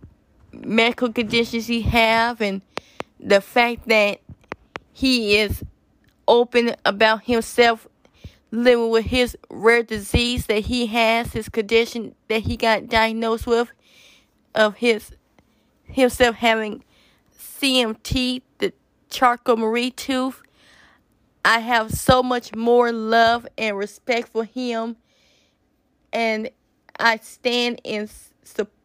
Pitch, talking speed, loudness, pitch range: 230 Hz, 110 wpm, -20 LUFS, 225-245 Hz